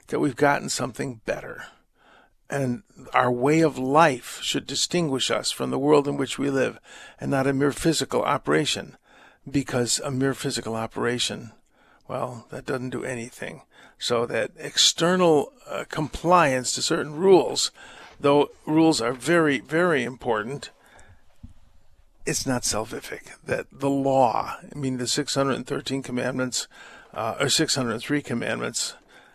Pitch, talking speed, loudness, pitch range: 135 Hz, 135 wpm, -24 LUFS, 125-145 Hz